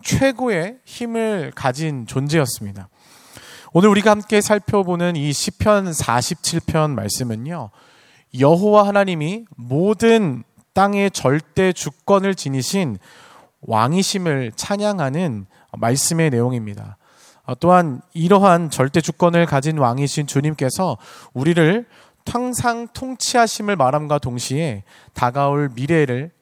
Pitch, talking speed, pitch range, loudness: 160 Hz, 245 characters per minute, 130-200 Hz, -18 LUFS